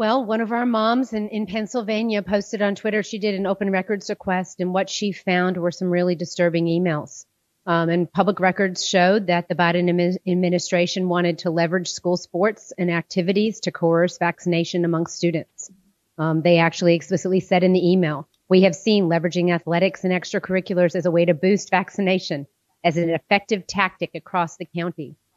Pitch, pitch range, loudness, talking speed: 180 Hz, 175-195 Hz, -21 LUFS, 175 wpm